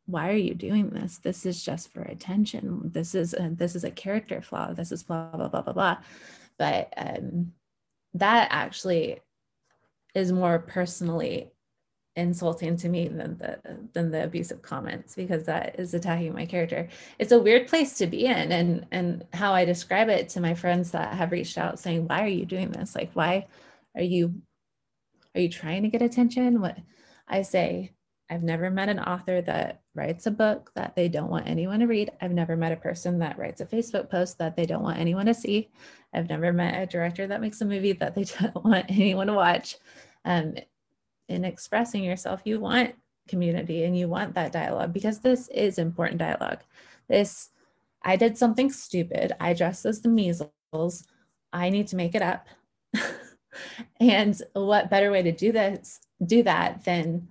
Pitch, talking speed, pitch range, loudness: 180 Hz, 185 wpm, 170-210 Hz, -27 LUFS